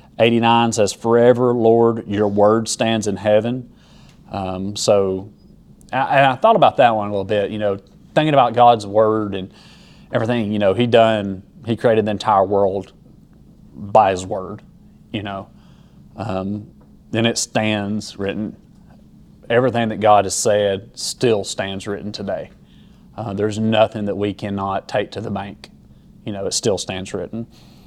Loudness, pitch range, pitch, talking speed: -18 LUFS, 100-115 Hz, 105 Hz, 155 wpm